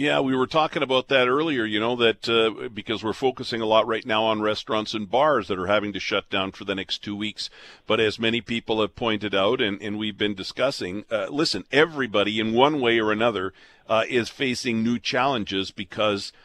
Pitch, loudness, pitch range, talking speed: 110 Hz, -23 LUFS, 105-120 Hz, 215 wpm